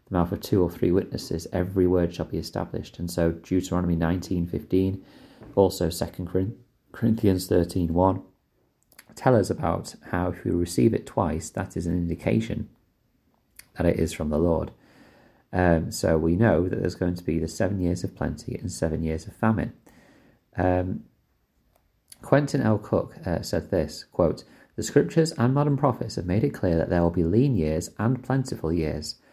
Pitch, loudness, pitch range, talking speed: 90 Hz, -25 LUFS, 85-110 Hz, 170 wpm